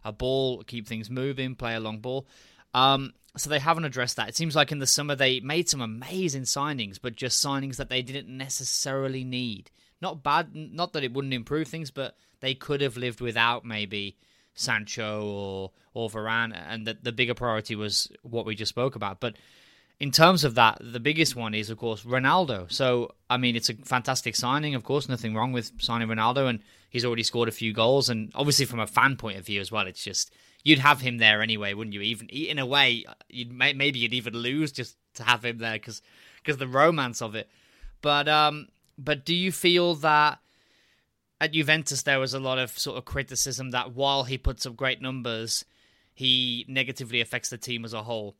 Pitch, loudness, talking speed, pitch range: 125 Hz, -26 LUFS, 210 wpm, 115-140 Hz